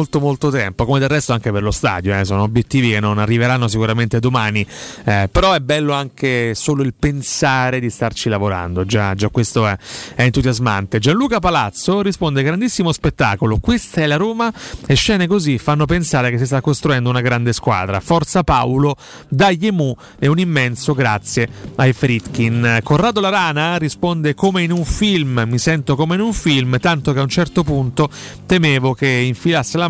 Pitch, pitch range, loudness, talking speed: 135 Hz, 120-160 Hz, -16 LUFS, 180 wpm